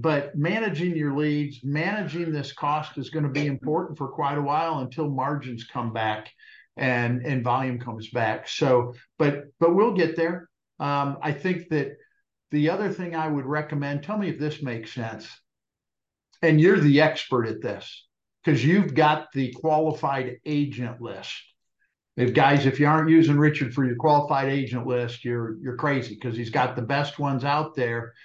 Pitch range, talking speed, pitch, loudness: 125-155 Hz, 175 wpm, 145 Hz, -24 LUFS